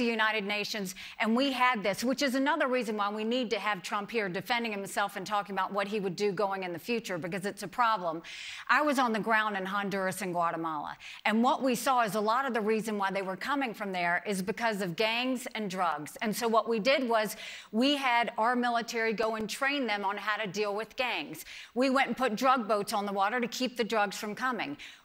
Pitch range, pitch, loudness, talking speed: 200-245 Hz, 220 Hz, -30 LUFS, 240 wpm